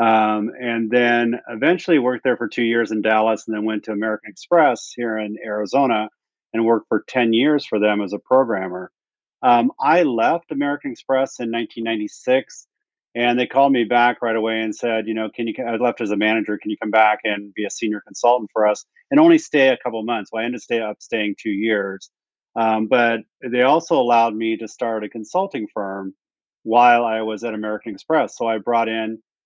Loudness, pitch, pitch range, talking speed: -19 LUFS, 115 Hz, 110-120 Hz, 205 wpm